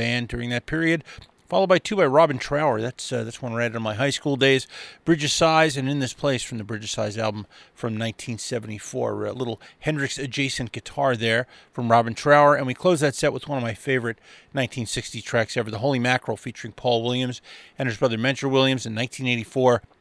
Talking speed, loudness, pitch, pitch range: 205 wpm, -23 LUFS, 125 Hz, 115-140 Hz